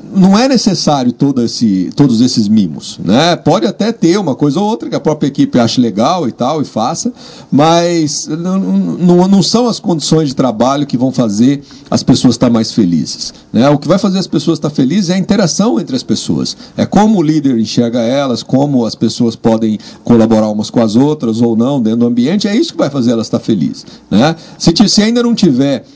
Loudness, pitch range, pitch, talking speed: -11 LUFS, 125-205 Hz, 160 Hz, 215 wpm